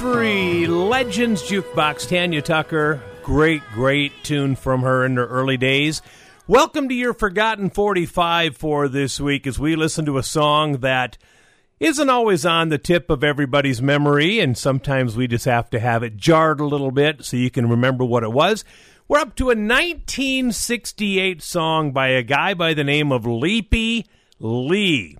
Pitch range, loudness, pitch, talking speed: 135-185 Hz, -19 LUFS, 150 Hz, 170 wpm